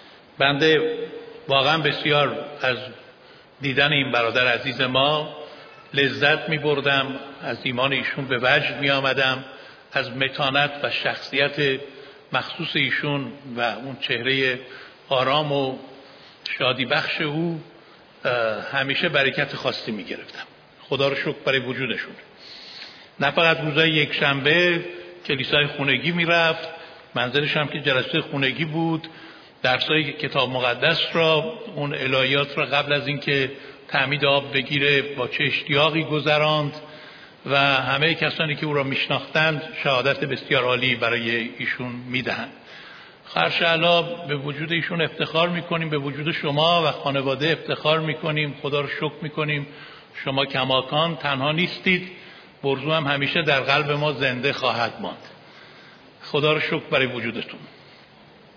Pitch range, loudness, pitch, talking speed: 135-155 Hz, -21 LUFS, 145 Hz, 125 wpm